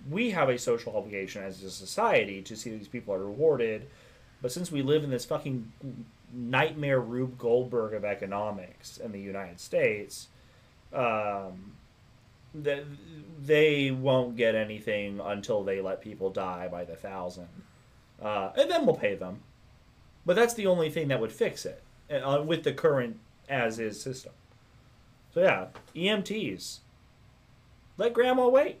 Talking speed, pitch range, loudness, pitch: 150 wpm, 105-155 Hz, -29 LUFS, 125 Hz